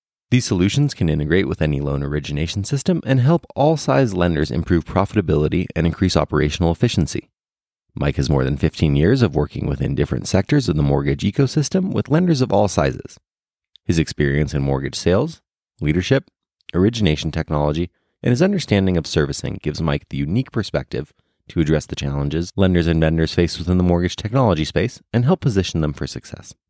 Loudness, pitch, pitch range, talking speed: -19 LUFS, 90 Hz, 75-120 Hz, 175 wpm